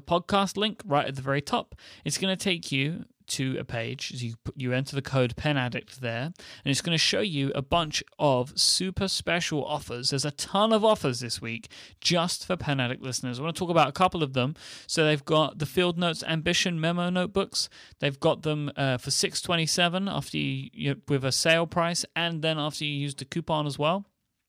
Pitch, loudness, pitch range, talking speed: 150 Hz, -27 LUFS, 135-170 Hz, 210 wpm